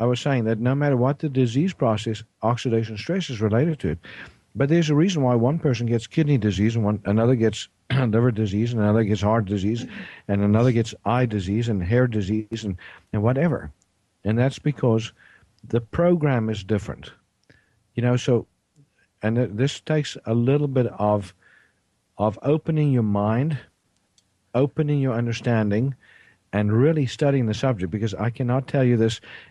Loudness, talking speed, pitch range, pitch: -23 LUFS, 170 wpm, 105-135 Hz, 115 Hz